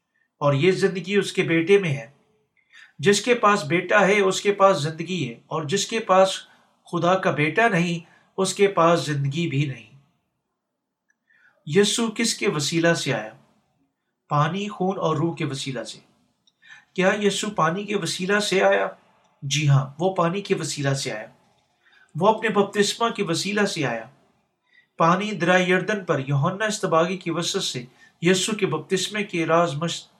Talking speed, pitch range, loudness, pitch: 160 wpm, 160-200 Hz, -22 LUFS, 185 Hz